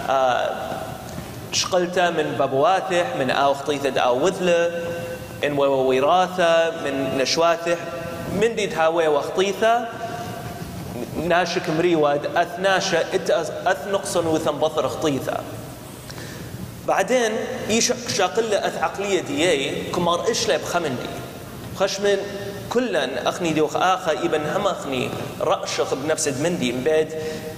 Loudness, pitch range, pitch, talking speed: -22 LUFS, 155-195 Hz, 170 Hz, 95 wpm